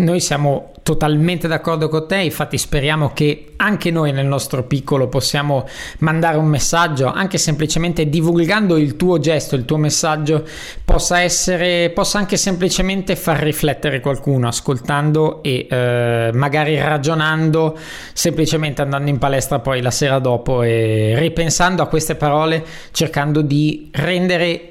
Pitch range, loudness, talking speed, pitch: 140-170 Hz, -16 LUFS, 135 wpm, 155 Hz